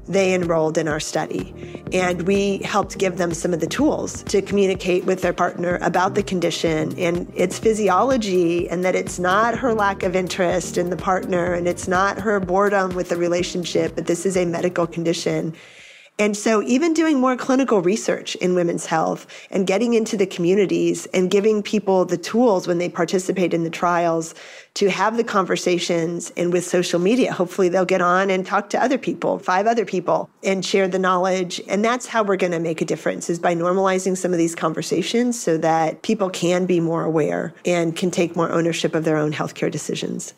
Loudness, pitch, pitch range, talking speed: -20 LUFS, 180 Hz, 170-195 Hz, 200 wpm